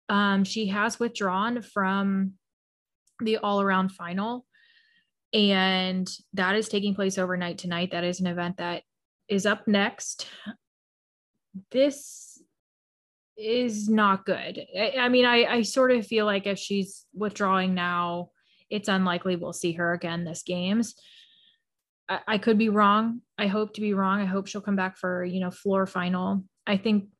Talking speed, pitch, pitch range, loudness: 155 wpm, 200 Hz, 185-215 Hz, -26 LUFS